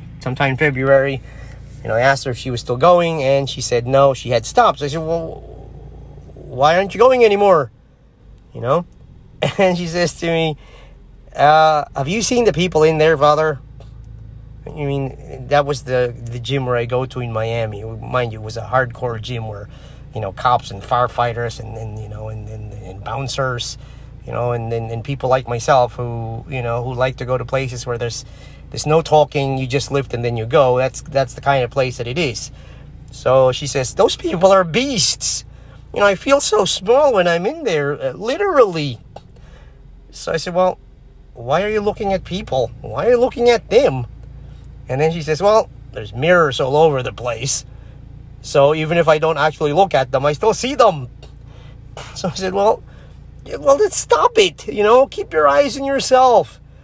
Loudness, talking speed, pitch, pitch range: -17 LUFS, 205 wpm, 135 Hz, 125-165 Hz